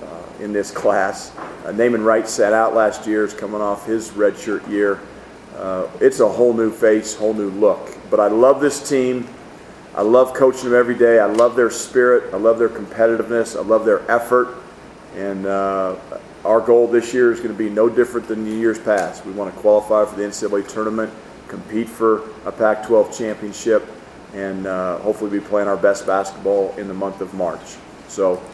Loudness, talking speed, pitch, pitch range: -18 LUFS, 195 wpm, 110 Hz, 100-115 Hz